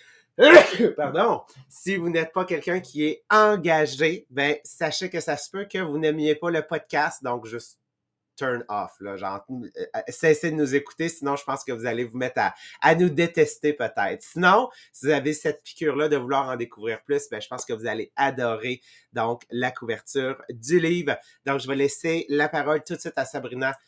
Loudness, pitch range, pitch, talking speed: -23 LUFS, 130-165 Hz, 150 Hz, 195 wpm